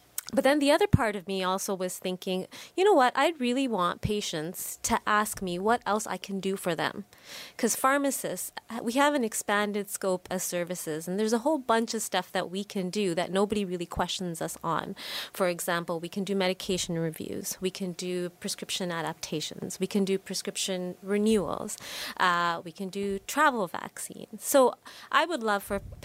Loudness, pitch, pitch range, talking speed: -29 LUFS, 195 Hz, 180-220 Hz, 185 wpm